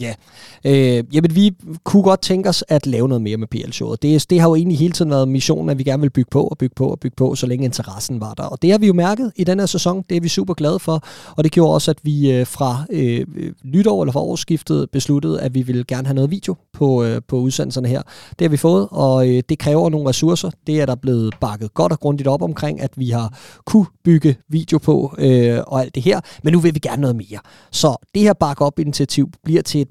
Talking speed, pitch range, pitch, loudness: 255 wpm, 130-165 Hz, 145 Hz, -17 LUFS